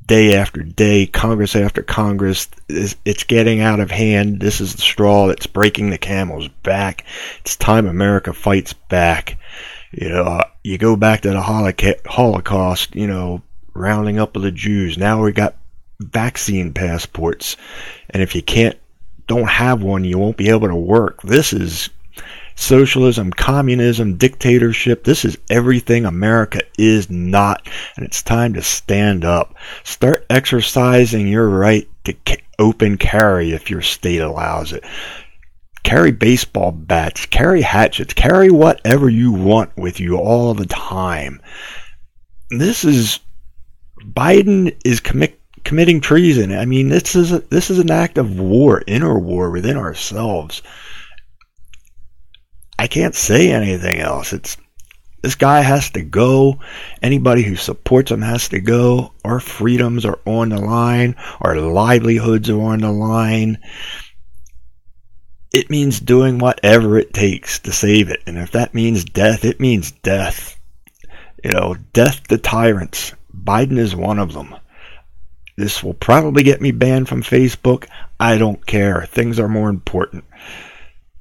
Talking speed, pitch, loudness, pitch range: 145 wpm, 105 Hz, -15 LUFS, 95-120 Hz